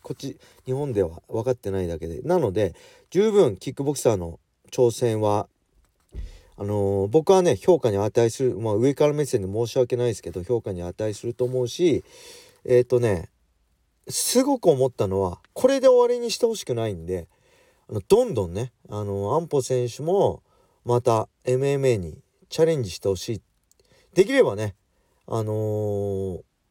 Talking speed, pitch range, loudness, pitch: 305 characters per minute, 95-135 Hz, -23 LUFS, 115 Hz